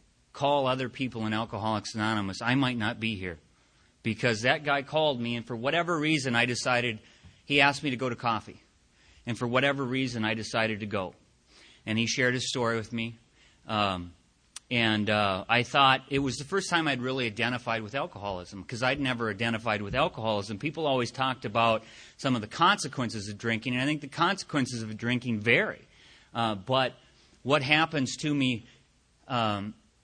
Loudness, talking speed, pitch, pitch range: -28 LUFS, 180 wpm, 120 Hz, 110-135 Hz